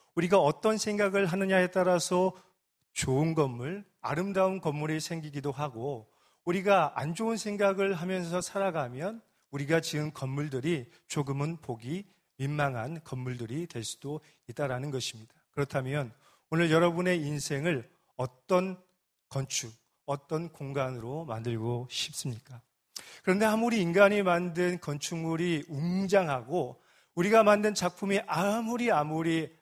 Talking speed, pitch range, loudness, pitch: 290 characters per minute, 140-185 Hz, -30 LUFS, 165 Hz